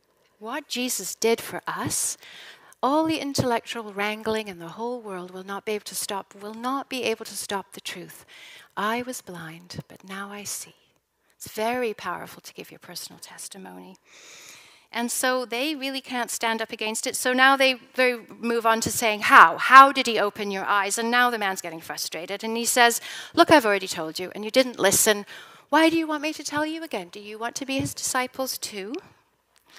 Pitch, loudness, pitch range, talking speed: 230 Hz, -23 LUFS, 205-260 Hz, 205 wpm